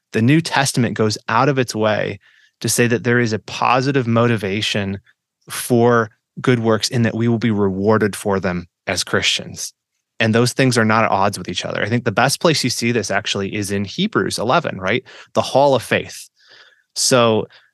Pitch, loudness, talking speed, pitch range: 115 Hz, -17 LUFS, 195 wpm, 105-120 Hz